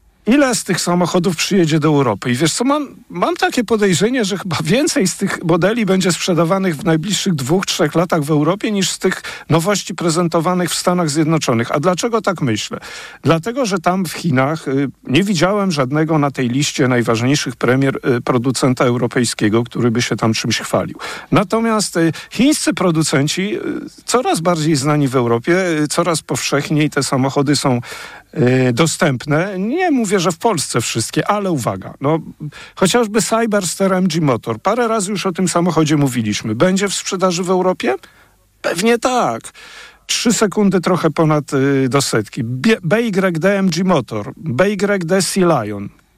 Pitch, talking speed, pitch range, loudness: 170 Hz, 160 wpm, 140-195 Hz, -16 LUFS